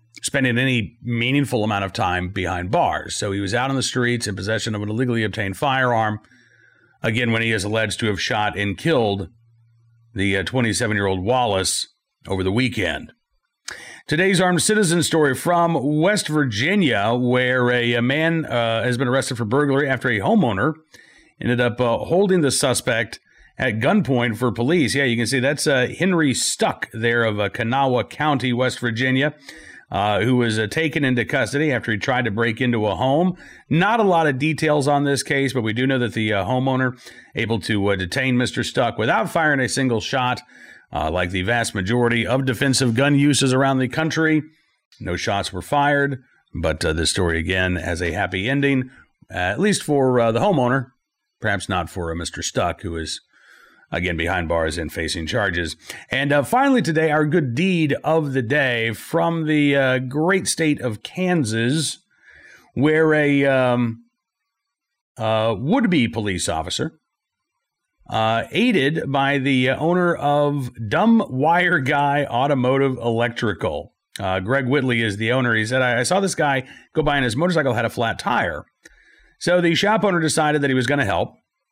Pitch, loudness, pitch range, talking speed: 125 Hz, -20 LUFS, 110-145 Hz, 175 wpm